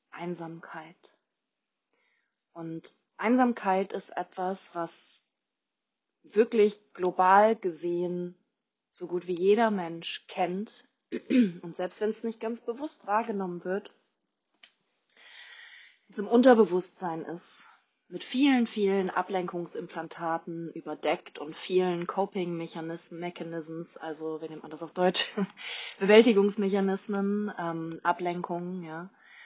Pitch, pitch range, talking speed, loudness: 185 Hz, 170-210 Hz, 95 wpm, -29 LUFS